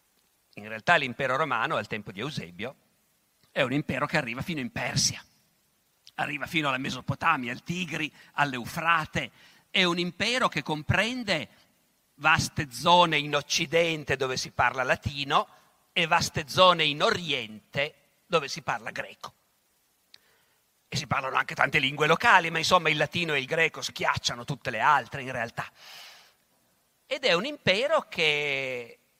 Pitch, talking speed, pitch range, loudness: 155 Hz, 145 wpm, 135-175 Hz, -26 LUFS